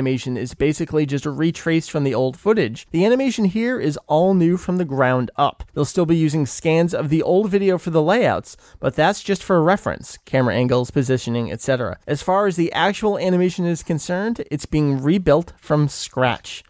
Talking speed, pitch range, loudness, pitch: 195 wpm, 135-180 Hz, -20 LUFS, 155 Hz